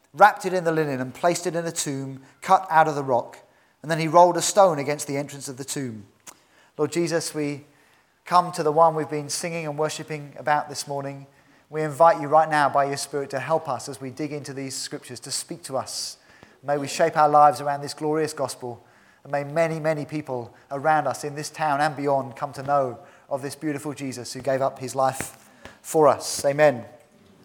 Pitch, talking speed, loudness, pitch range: 145 Hz, 220 wpm, -23 LUFS, 140-155 Hz